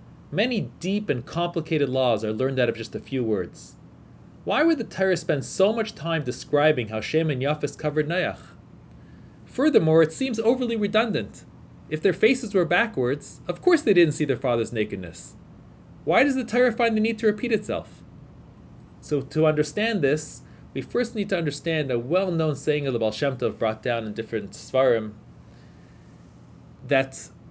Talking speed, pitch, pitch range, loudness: 175 wpm, 155 Hz, 125-210 Hz, -24 LUFS